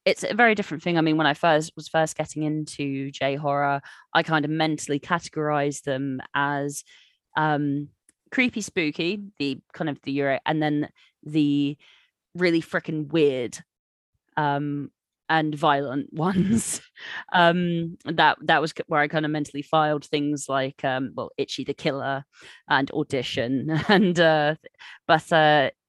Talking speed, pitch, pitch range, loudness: 150 wpm, 150 Hz, 140-160 Hz, -24 LUFS